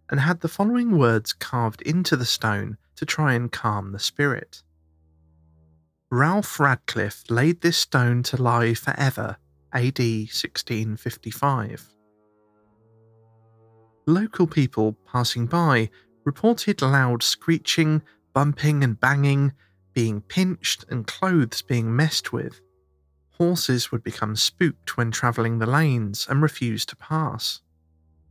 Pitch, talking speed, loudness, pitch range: 120 Hz, 115 wpm, -23 LUFS, 110-145 Hz